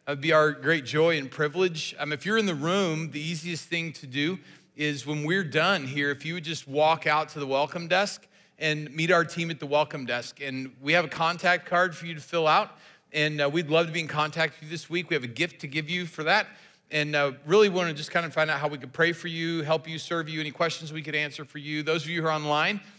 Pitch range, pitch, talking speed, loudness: 150-170 Hz, 160 Hz, 280 wpm, -26 LUFS